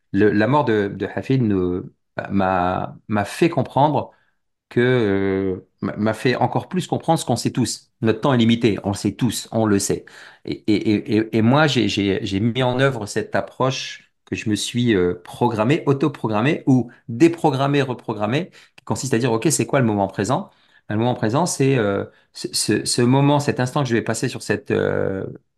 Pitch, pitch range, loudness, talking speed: 115 Hz, 105-135 Hz, -20 LUFS, 190 wpm